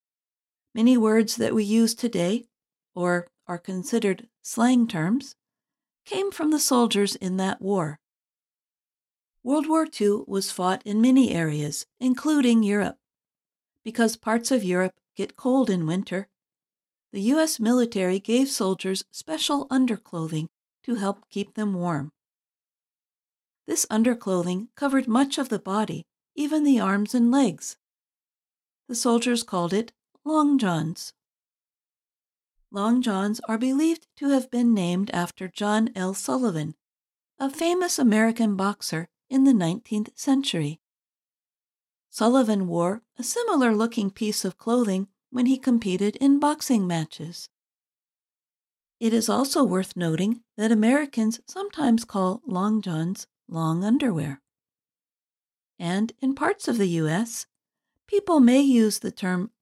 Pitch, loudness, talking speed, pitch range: 220 Hz, -24 LUFS, 125 wpm, 190-255 Hz